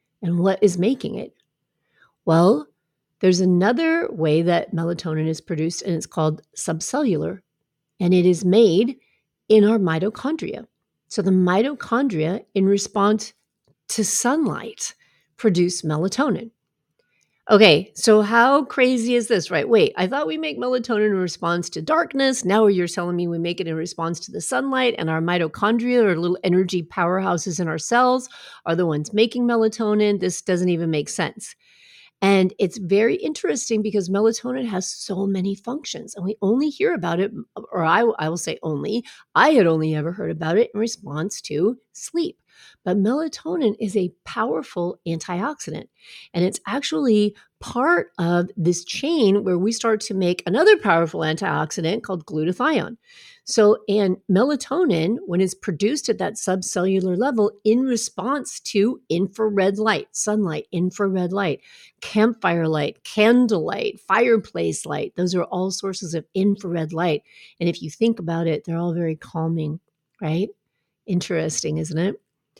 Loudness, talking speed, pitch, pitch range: -21 LUFS, 150 wpm, 195 Hz, 175-230 Hz